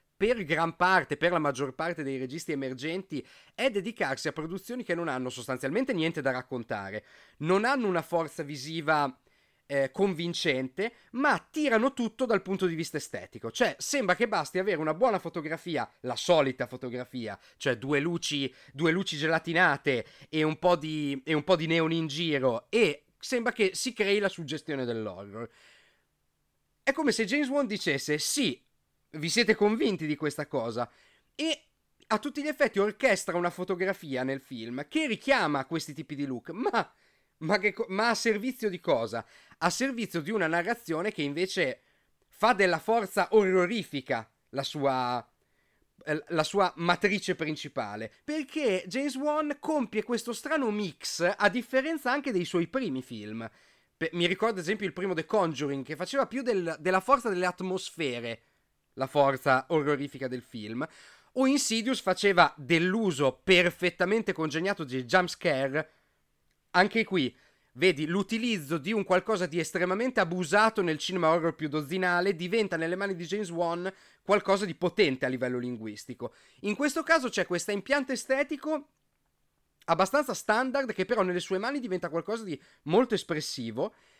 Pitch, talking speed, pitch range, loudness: 180 Hz, 155 wpm, 150-215 Hz, -29 LUFS